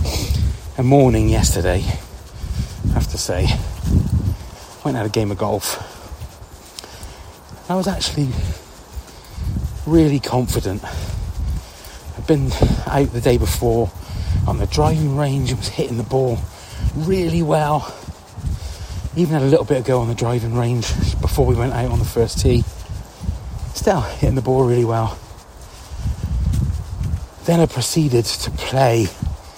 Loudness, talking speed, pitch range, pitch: -19 LUFS, 130 wpm, 90-130 Hz, 110 Hz